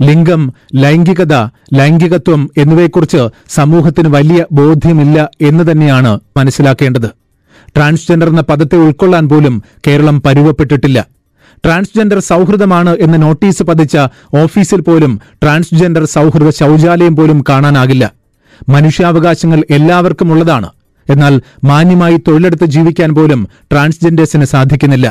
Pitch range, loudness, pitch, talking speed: 140-170 Hz, -8 LUFS, 155 Hz, 95 wpm